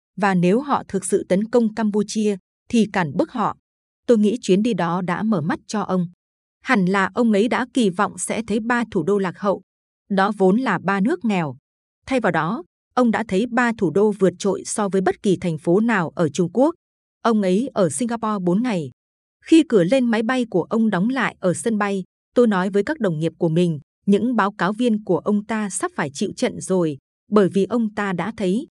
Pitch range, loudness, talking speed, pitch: 185-230 Hz, -20 LUFS, 225 wpm, 205 Hz